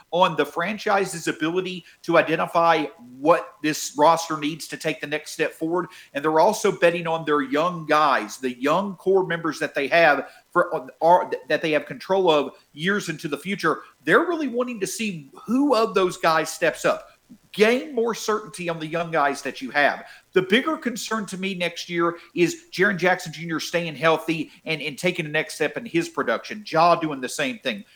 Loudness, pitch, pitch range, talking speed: -23 LUFS, 170 Hz, 155-200 Hz, 195 wpm